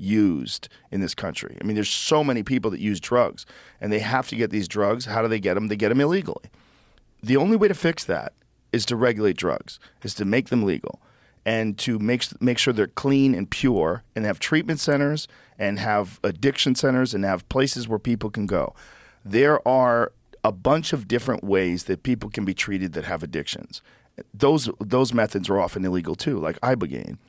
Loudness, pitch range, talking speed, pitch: -23 LUFS, 105-130 Hz, 200 wpm, 115 Hz